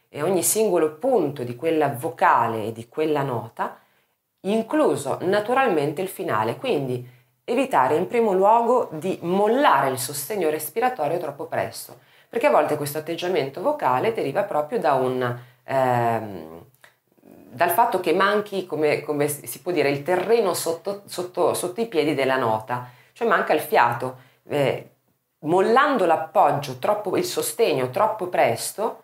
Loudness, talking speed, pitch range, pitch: -22 LUFS, 140 wpm, 130-200 Hz, 155 Hz